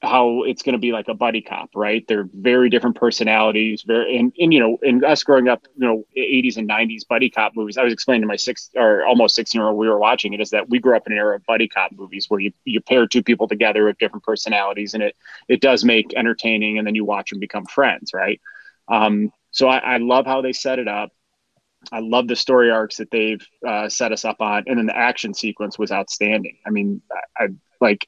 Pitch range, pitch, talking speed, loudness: 105-125 Hz, 115 Hz, 250 wpm, -18 LUFS